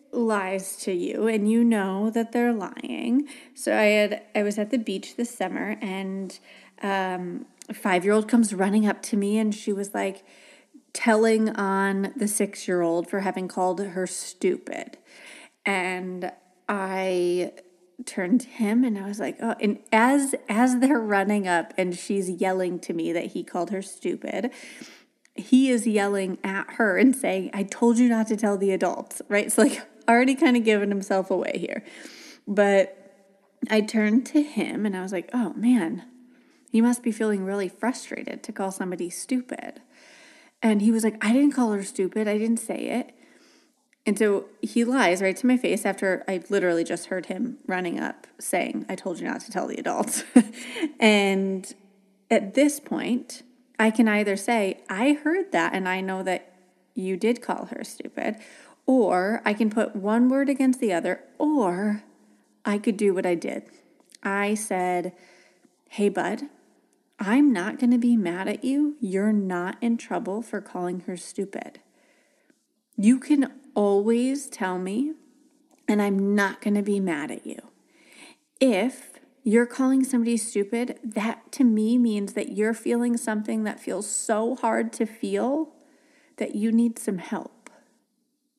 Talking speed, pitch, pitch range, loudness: 165 wpm, 220 Hz, 195-255 Hz, -25 LUFS